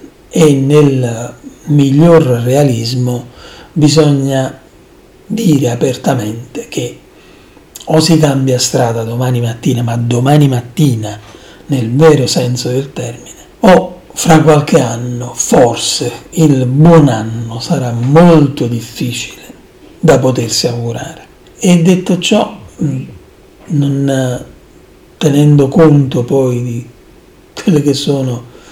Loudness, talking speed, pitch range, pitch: -11 LUFS, 100 wpm, 120-155 Hz, 135 Hz